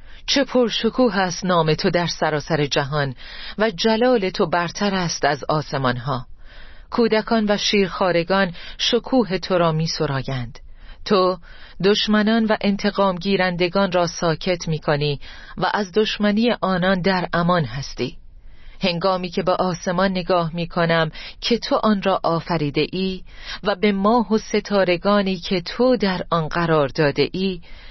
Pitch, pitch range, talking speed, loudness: 185 Hz, 160-205 Hz, 140 wpm, -20 LUFS